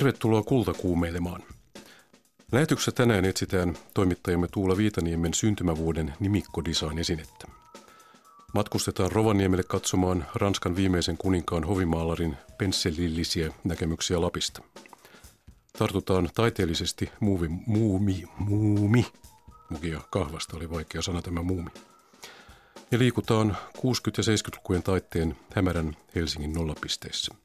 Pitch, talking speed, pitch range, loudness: 90 Hz, 95 wpm, 85-105 Hz, -27 LUFS